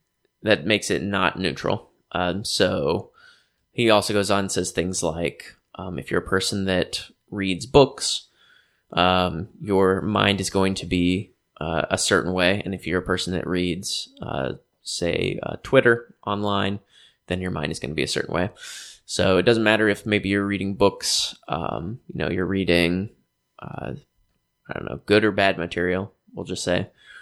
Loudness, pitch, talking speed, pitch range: -23 LUFS, 95 Hz, 180 wpm, 90-100 Hz